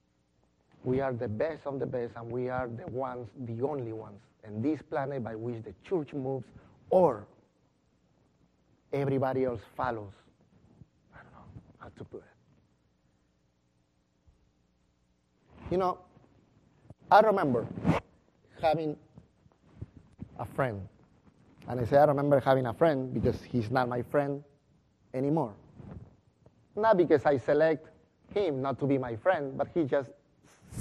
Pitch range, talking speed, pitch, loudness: 105-140 Hz, 130 wpm, 125 Hz, -30 LUFS